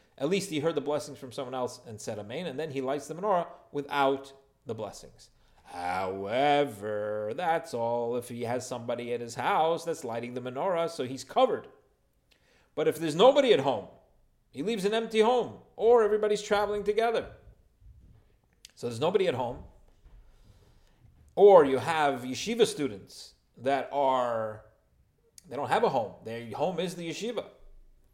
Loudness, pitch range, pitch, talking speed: -28 LUFS, 120-195 Hz, 140 Hz, 160 wpm